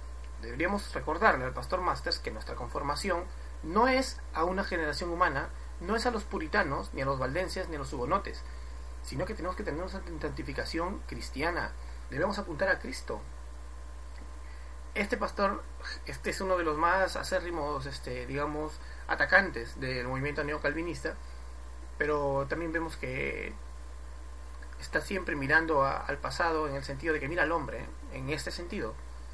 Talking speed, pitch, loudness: 155 wpm, 115 Hz, -32 LUFS